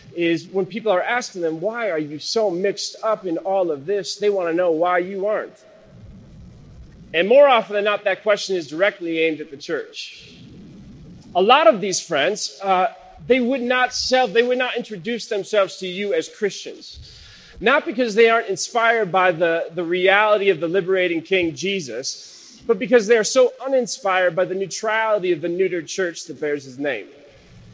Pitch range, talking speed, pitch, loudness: 180-230 Hz, 185 wpm, 195 Hz, -20 LUFS